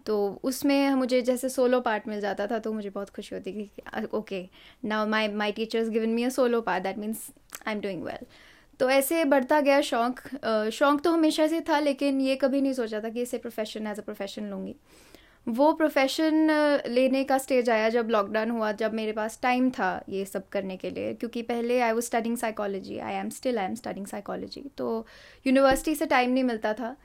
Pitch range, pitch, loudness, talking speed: 215-270 Hz, 235 Hz, -27 LUFS, 210 wpm